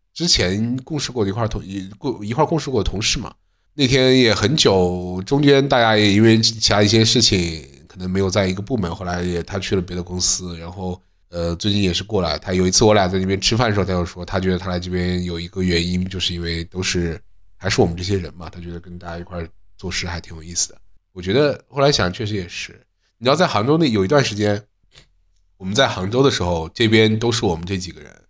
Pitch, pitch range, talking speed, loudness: 95 Hz, 90-110 Hz, 350 characters per minute, -18 LUFS